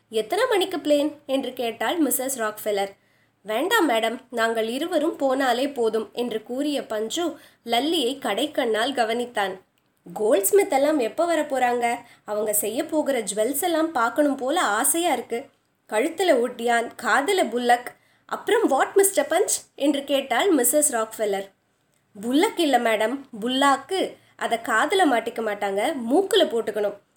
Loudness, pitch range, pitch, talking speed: -23 LUFS, 225-310 Hz, 255 Hz, 125 wpm